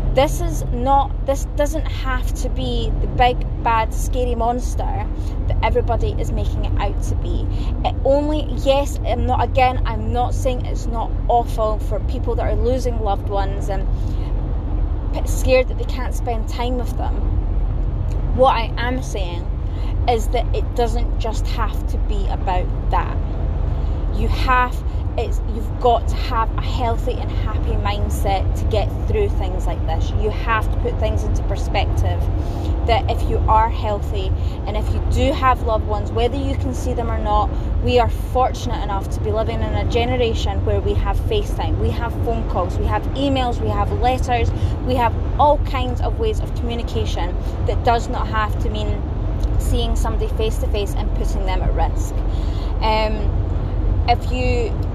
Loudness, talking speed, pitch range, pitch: -21 LUFS, 175 wpm, 80-100 Hz, 90 Hz